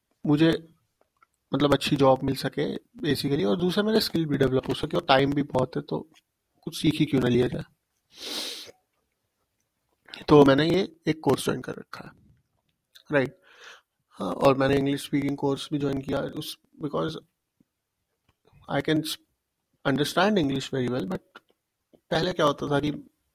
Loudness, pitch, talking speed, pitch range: -25 LUFS, 145 Hz, 155 wpm, 135-155 Hz